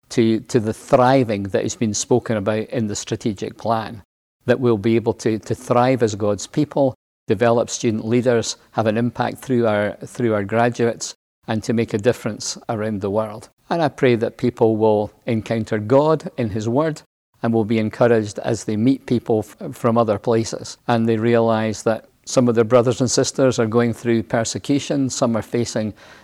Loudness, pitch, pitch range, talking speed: -20 LUFS, 115 Hz, 110-125 Hz, 185 wpm